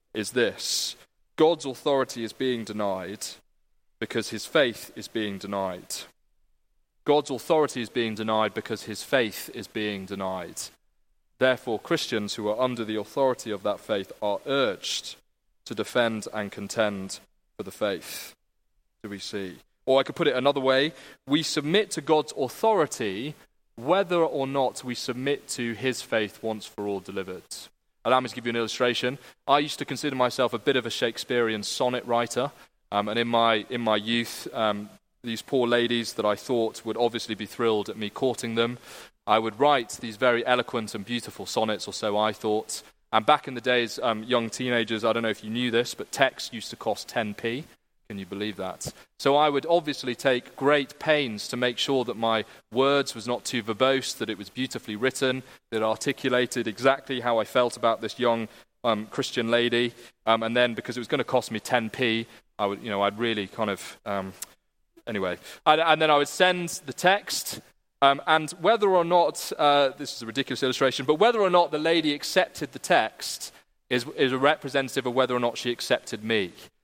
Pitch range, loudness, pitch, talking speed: 110-135 Hz, -26 LUFS, 120 Hz, 190 wpm